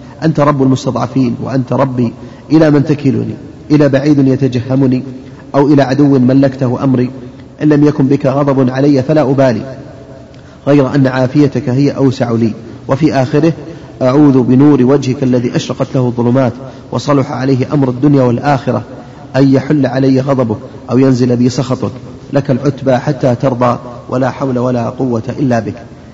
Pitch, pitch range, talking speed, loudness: 135 Hz, 125-140 Hz, 140 wpm, -11 LUFS